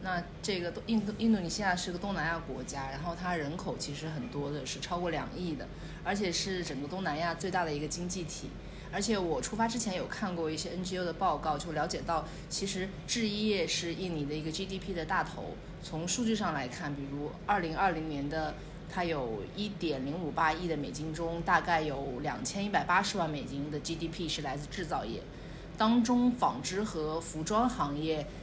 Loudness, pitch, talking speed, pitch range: -33 LUFS, 170 Hz, 310 characters per minute, 155-190 Hz